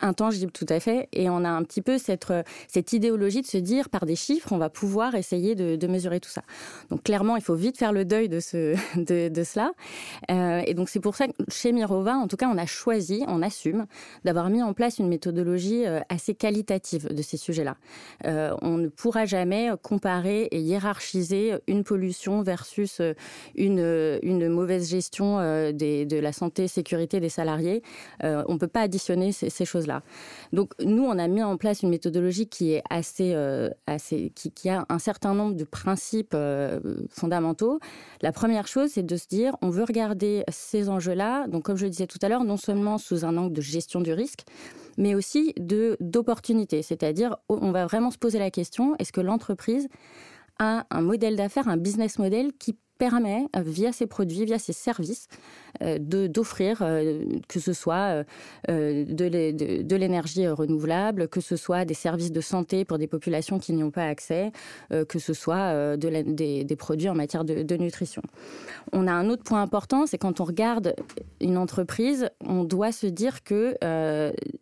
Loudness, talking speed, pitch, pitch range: -26 LUFS, 200 wpm, 185 Hz, 170-215 Hz